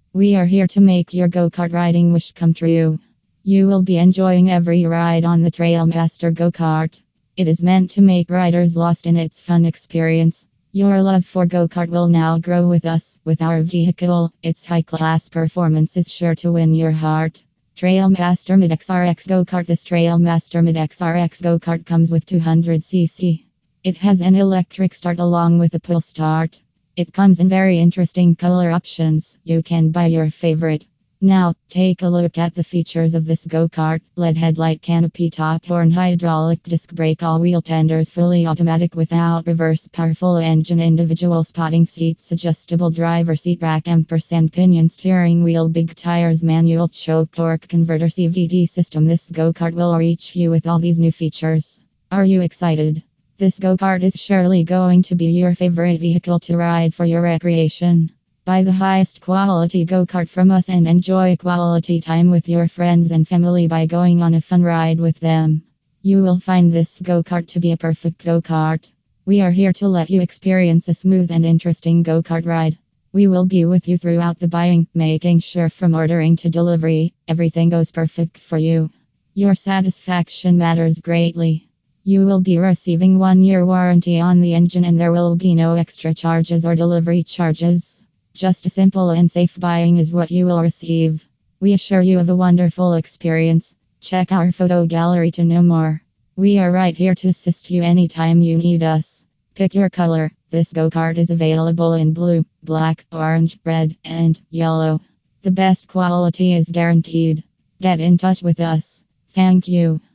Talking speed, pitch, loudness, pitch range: 180 wpm, 170 Hz, -16 LUFS, 165-180 Hz